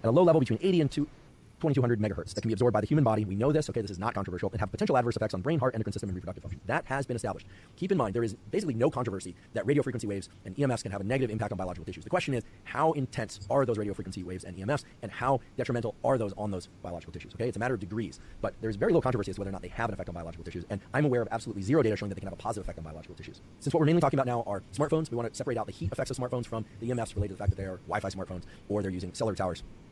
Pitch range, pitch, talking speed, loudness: 95-130 Hz, 110 Hz, 325 wpm, -31 LUFS